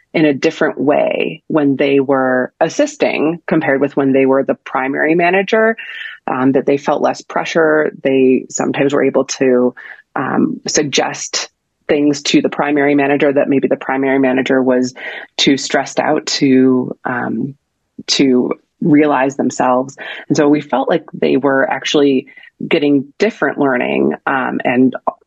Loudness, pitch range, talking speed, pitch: -14 LUFS, 130-150 Hz, 145 wpm, 140 Hz